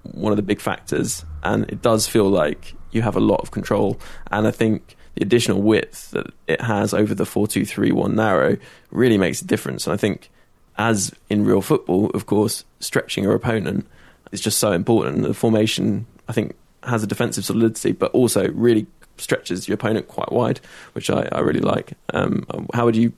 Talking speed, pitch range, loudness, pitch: 200 wpm, 100-115 Hz, -20 LUFS, 105 Hz